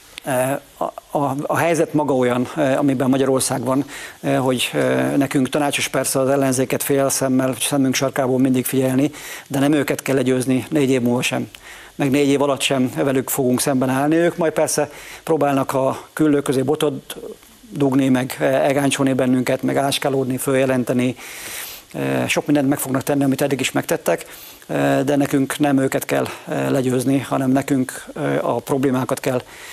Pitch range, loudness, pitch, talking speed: 130-145 Hz, -19 LUFS, 135 Hz, 150 wpm